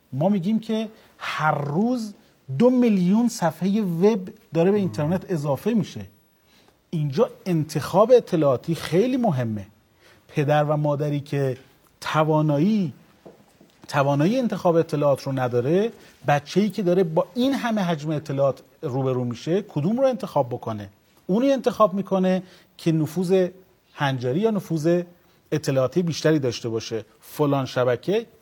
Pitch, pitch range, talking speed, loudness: 165 Hz, 140-195 Hz, 120 wpm, -23 LUFS